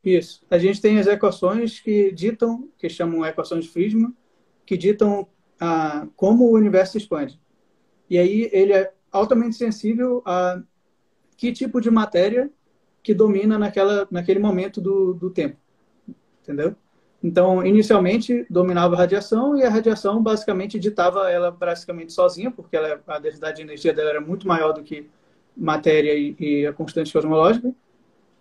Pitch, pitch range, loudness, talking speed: 195 Hz, 175-220 Hz, -20 LUFS, 150 wpm